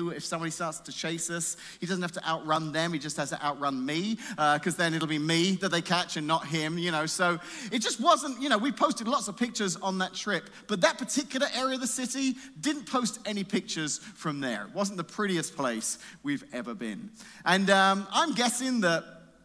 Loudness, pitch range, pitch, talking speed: -29 LUFS, 160-245 Hz, 185 Hz, 220 wpm